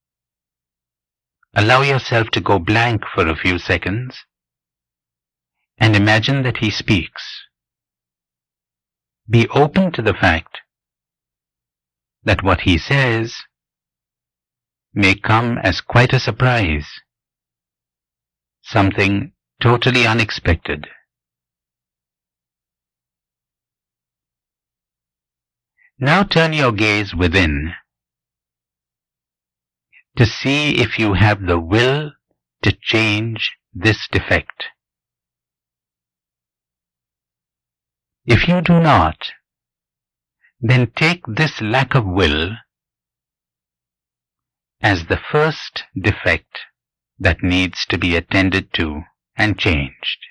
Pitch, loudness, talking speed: 95 Hz, -16 LUFS, 85 wpm